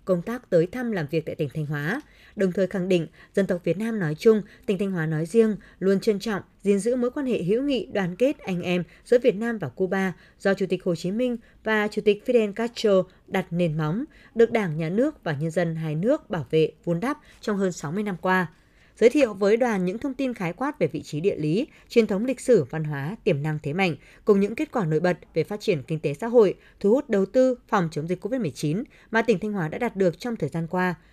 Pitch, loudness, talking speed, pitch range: 195 Hz, -25 LUFS, 255 wpm, 170-230 Hz